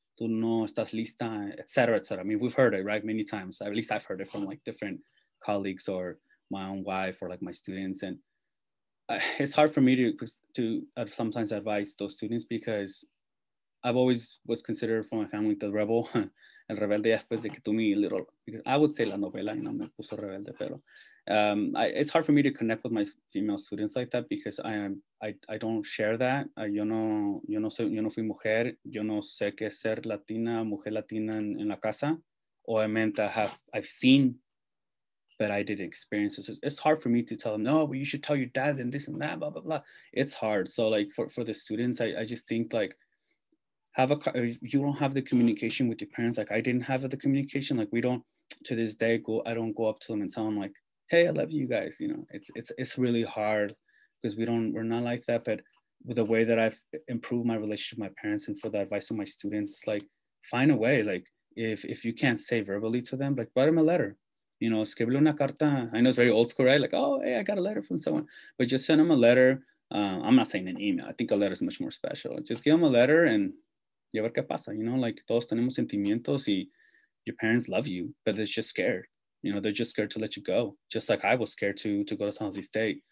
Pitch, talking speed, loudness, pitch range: 115 Hz, 240 wpm, -29 LUFS, 105-130 Hz